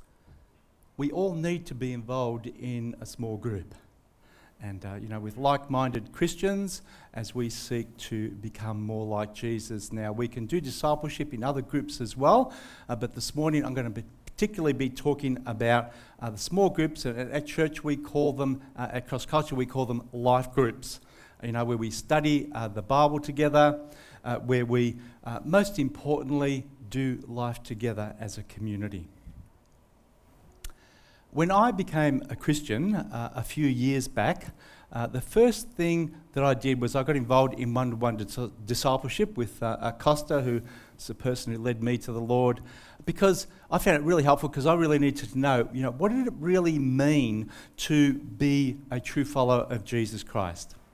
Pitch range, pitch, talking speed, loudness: 115-145 Hz, 125 Hz, 180 wpm, -28 LUFS